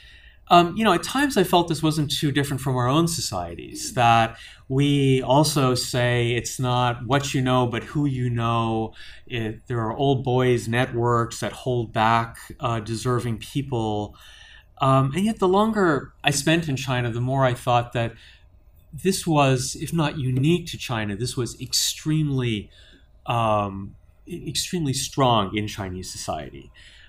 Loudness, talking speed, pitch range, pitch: -23 LUFS, 155 wpm, 115-145 Hz, 125 Hz